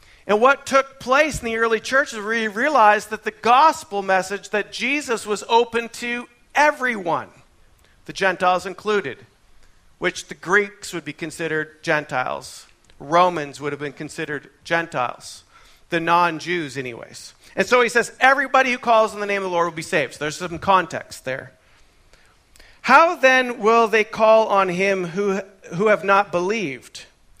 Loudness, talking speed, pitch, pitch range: -20 LUFS, 160 wpm, 200 Hz, 170-230 Hz